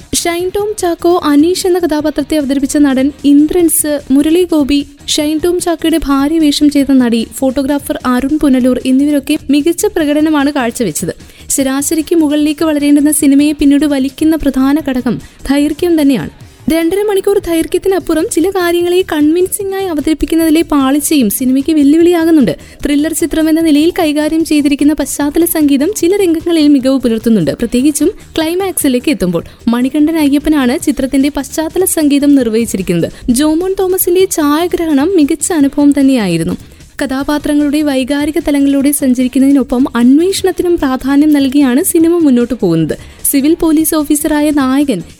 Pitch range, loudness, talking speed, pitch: 275-330 Hz, -11 LUFS, 115 wpm, 295 Hz